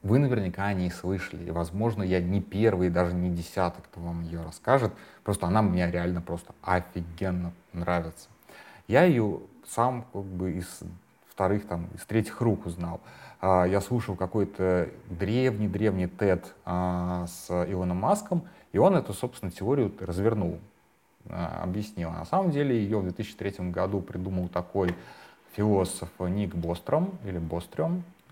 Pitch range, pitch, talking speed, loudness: 90-110 Hz, 95 Hz, 140 wpm, -29 LUFS